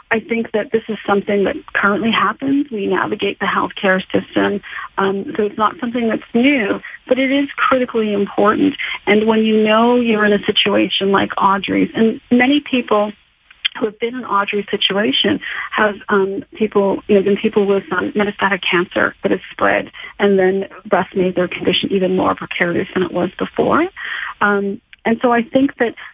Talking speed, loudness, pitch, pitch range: 180 wpm, -16 LUFS, 210 Hz, 195-235 Hz